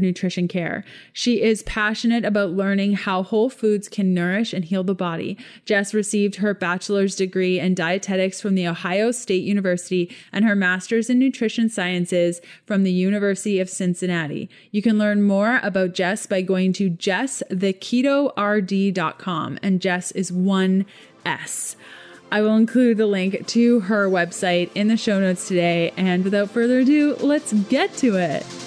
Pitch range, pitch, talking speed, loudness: 185-215 Hz, 195 Hz, 155 wpm, -21 LUFS